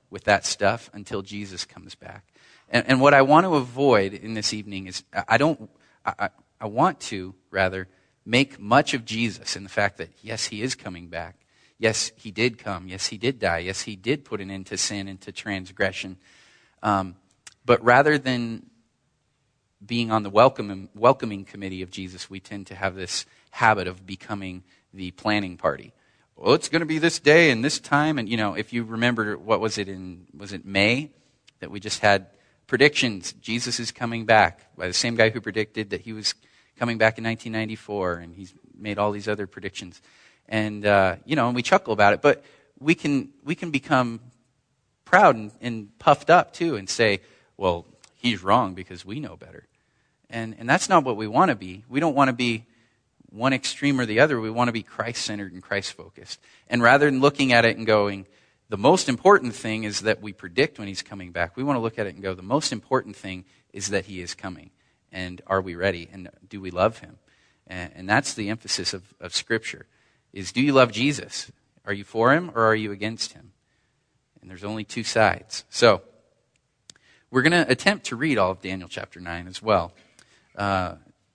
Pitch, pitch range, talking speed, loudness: 105 Hz, 95-120 Hz, 205 wpm, -23 LUFS